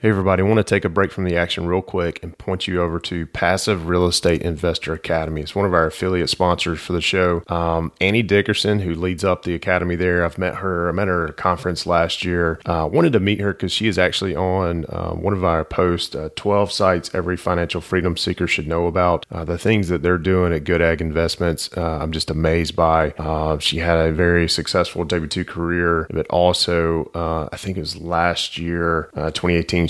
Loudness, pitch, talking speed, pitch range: -20 LUFS, 85 Hz, 225 wpm, 85-90 Hz